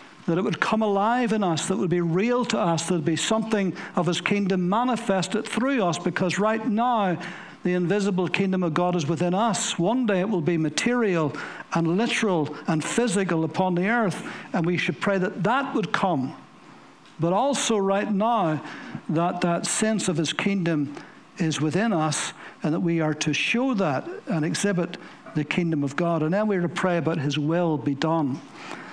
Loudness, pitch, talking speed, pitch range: -24 LUFS, 180 Hz, 195 wpm, 165-210 Hz